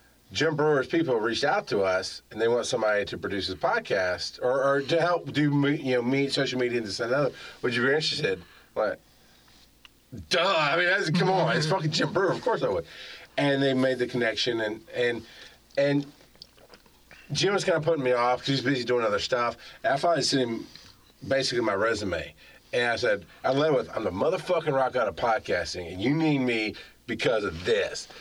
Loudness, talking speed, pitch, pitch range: -26 LUFS, 210 wpm, 135 Hz, 120-150 Hz